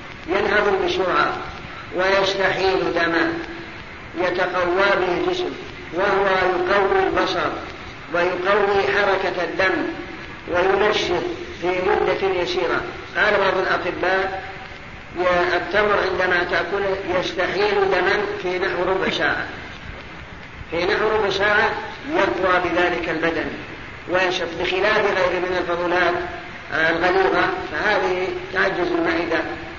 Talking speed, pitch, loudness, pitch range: 90 wpm, 185 Hz, -20 LUFS, 180-200 Hz